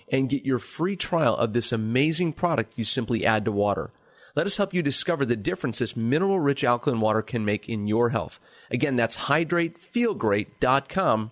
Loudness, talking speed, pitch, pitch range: -25 LUFS, 180 wpm, 125 Hz, 115-160 Hz